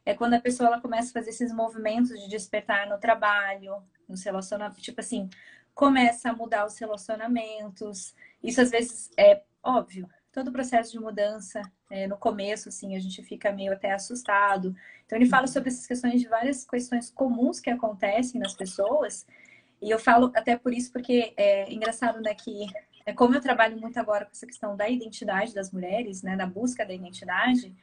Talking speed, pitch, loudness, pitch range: 185 wpm, 225 Hz, -26 LUFS, 205-245 Hz